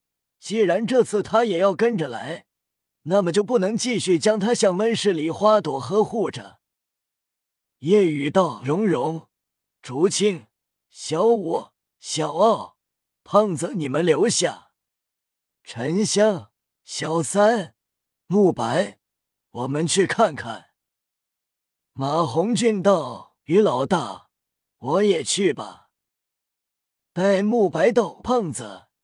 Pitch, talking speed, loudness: 175 Hz, 150 characters per minute, -21 LUFS